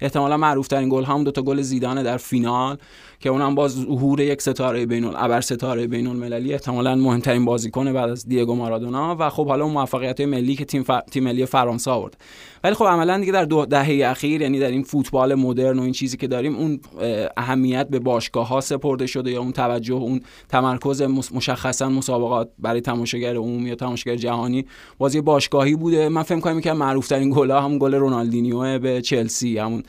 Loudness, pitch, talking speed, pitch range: -21 LUFS, 130 Hz, 195 wpm, 125-140 Hz